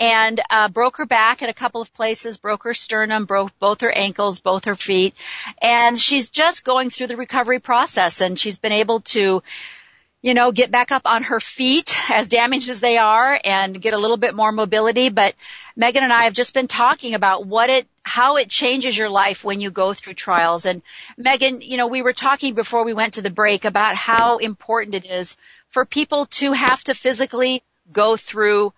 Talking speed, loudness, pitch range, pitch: 210 wpm, -18 LUFS, 205-255 Hz, 230 Hz